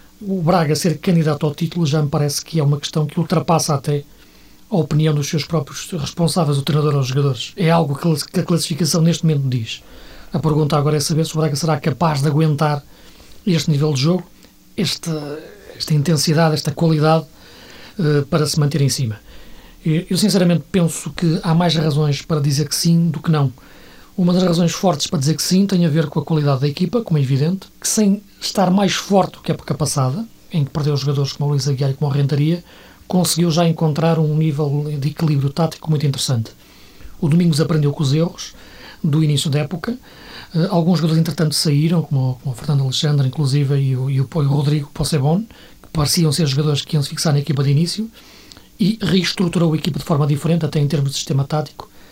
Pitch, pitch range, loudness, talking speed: 155 Hz, 145-170 Hz, -18 LUFS, 200 wpm